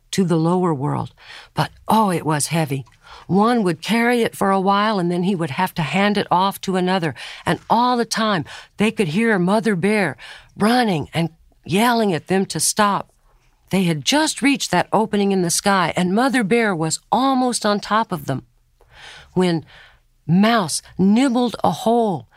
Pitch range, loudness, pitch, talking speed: 165-220 Hz, -19 LUFS, 195 Hz, 175 wpm